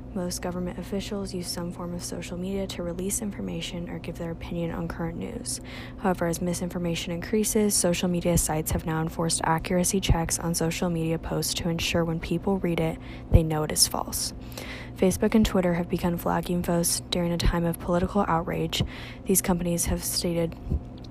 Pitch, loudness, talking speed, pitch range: 175 Hz, -27 LUFS, 180 wpm, 165-185 Hz